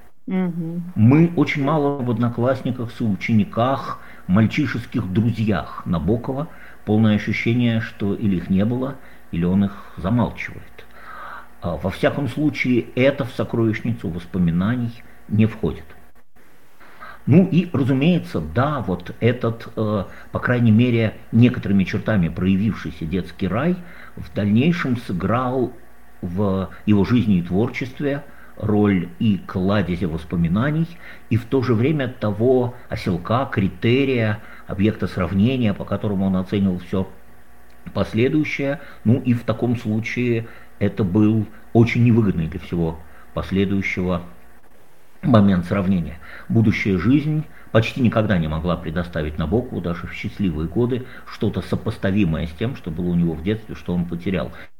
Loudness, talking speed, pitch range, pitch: -21 LUFS, 120 wpm, 95-125 Hz, 110 Hz